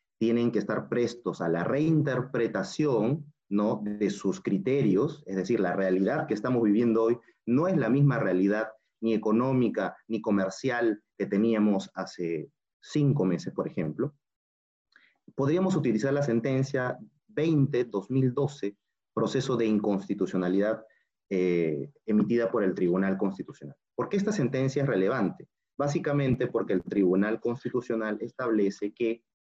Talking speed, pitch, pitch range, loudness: 130 wpm, 115 Hz, 100-130 Hz, -28 LUFS